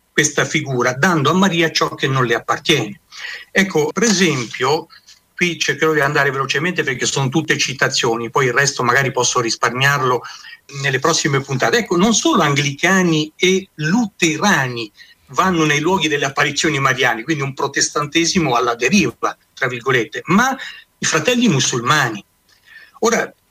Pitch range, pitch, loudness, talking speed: 135-175 Hz, 155 Hz, -16 LUFS, 140 wpm